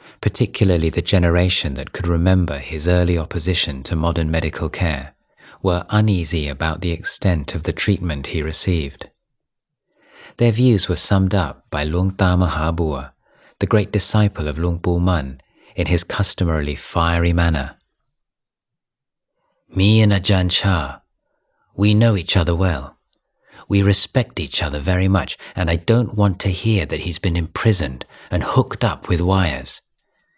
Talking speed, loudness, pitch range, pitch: 145 wpm, -19 LUFS, 80-100 Hz, 90 Hz